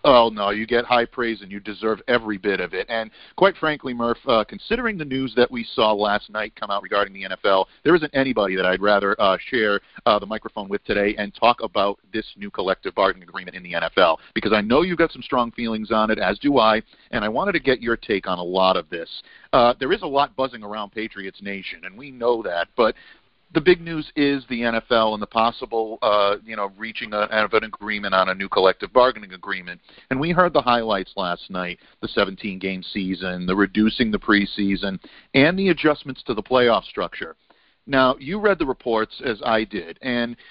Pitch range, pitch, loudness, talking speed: 100-130 Hz, 110 Hz, -21 LUFS, 215 wpm